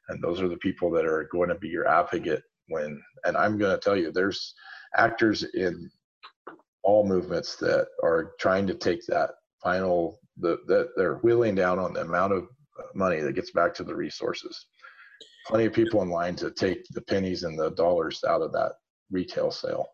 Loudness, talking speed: -27 LUFS, 195 wpm